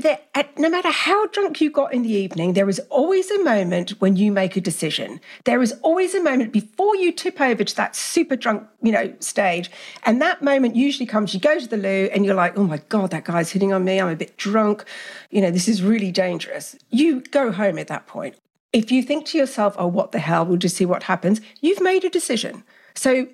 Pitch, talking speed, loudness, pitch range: 220 Hz, 235 wpm, -20 LUFS, 195-295 Hz